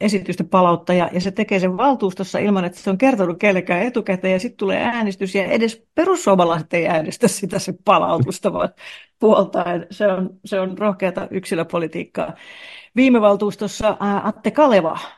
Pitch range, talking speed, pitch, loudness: 185-215 Hz, 155 wpm, 195 Hz, -19 LUFS